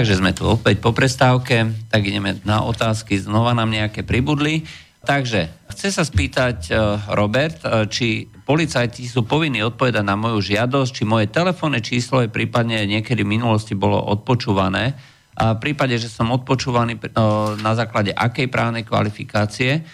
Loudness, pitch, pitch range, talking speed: -19 LUFS, 115 Hz, 105-130 Hz, 150 wpm